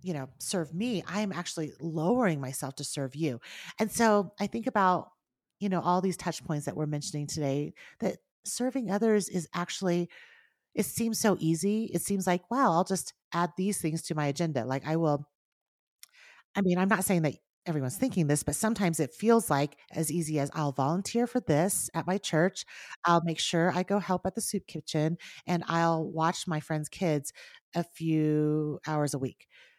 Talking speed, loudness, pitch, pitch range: 195 wpm, -30 LUFS, 170 Hz, 155-200 Hz